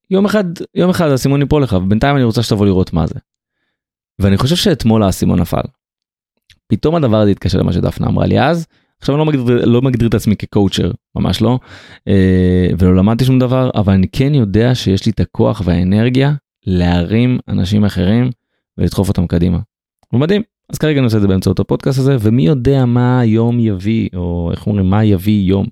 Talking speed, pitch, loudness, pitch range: 185 wpm, 110 Hz, -13 LUFS, 95-130 Hz